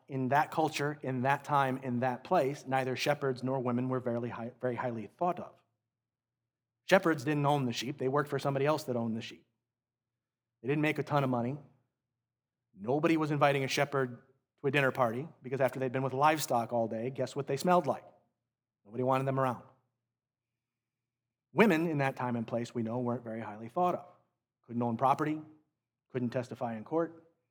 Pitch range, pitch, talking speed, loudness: 120-140 Hz, 130 Hz, 185 wpm, -32 LUFS